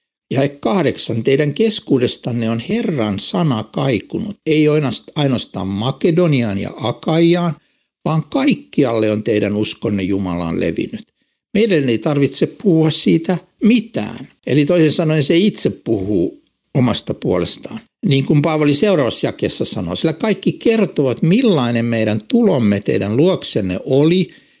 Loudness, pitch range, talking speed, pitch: -17 LUFS, 115-185 Hz, 120 wpm, 155 Hz